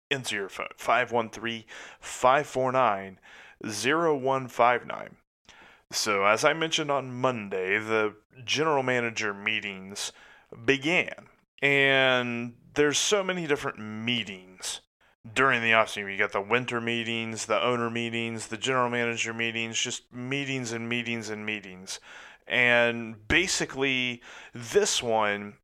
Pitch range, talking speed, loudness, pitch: 110-135 Hz, 110 wpm, -26 LUFS, 120 Hz